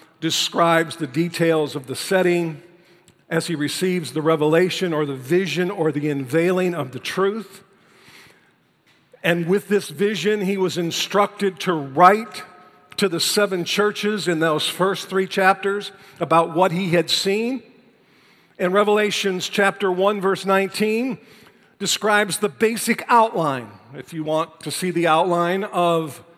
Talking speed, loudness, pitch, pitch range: 140 wpm, -20 LUFS, 180 Hz, 165-200 Hz